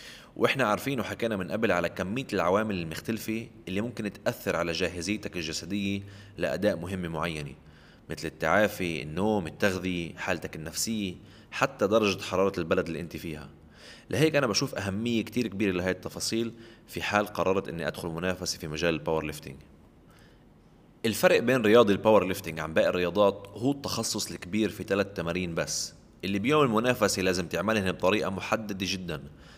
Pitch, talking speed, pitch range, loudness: 100 Hz, 145 wpm, 85-110 Hz, -28 LUFS